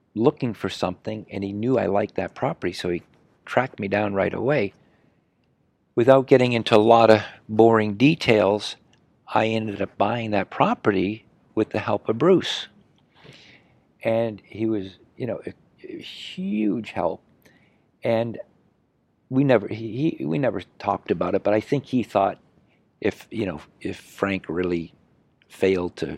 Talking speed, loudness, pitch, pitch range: 155 wpm, -23 LUFS, 110 Hz, 100-115 Hz